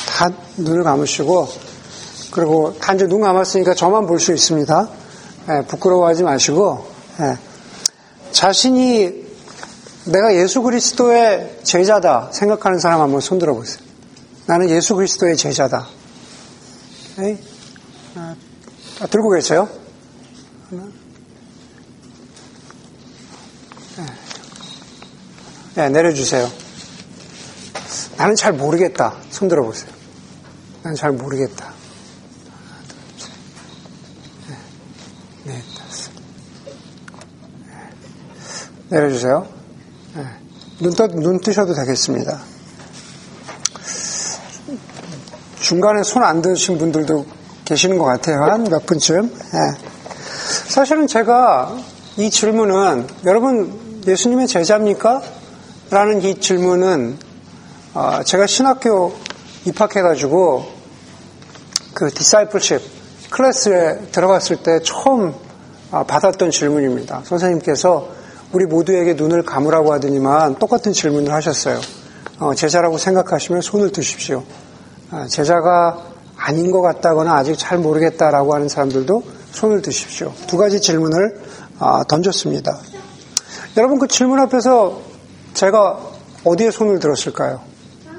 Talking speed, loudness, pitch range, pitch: 215 characters per minute, -15 LUFS, 160-210 Hz, 180 Hz